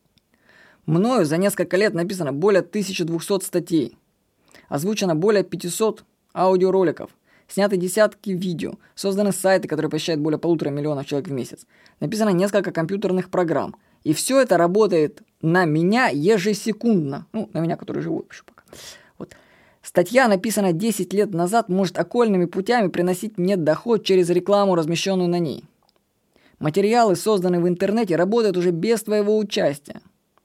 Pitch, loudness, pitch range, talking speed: 185 Hz, -21 LUFS, 170-210 Hz, 135 wpm